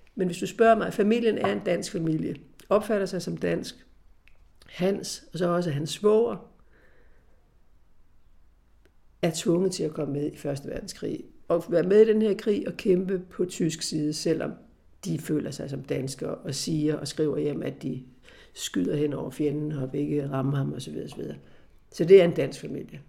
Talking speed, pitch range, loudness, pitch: 180 wpm, 140-190 Hz, -26 LUFS, 160 Hz